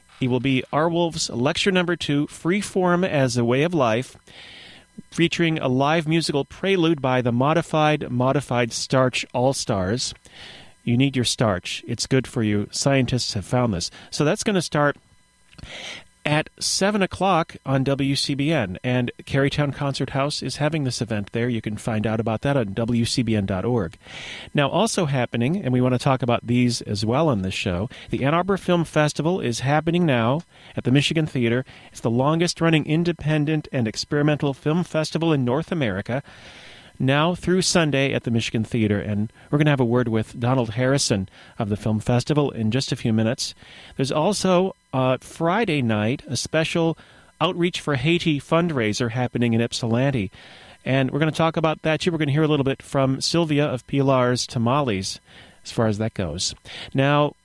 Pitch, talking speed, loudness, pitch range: 135 Hz, 180 wpm, -22 LUFS, 120-155 Hz